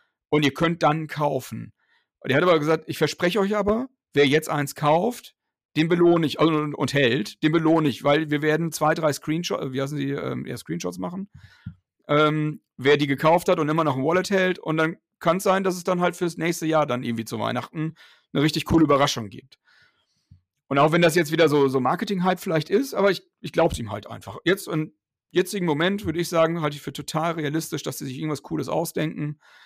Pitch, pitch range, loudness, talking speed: 155 Hz, 145-170 Hz, -23 LUFS, 220 wpm